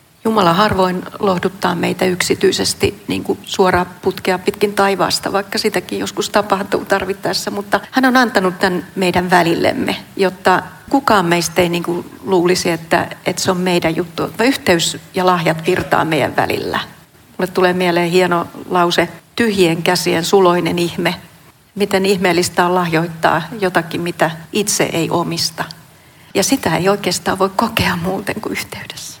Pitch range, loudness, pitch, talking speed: 170-195 Hz, -16 LUFS, 180 Hz, 140 wpm